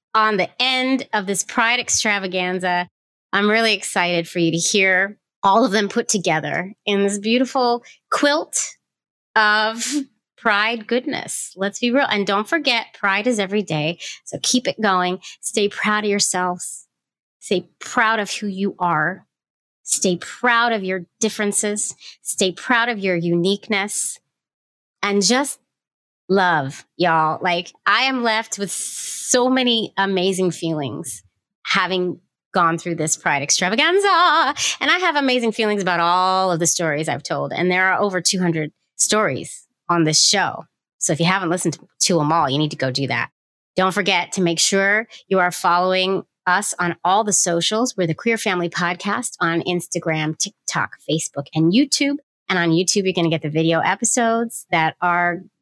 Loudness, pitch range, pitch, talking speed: -19 LUFS, 175-225 Hz, 195 Hz, 165 wpm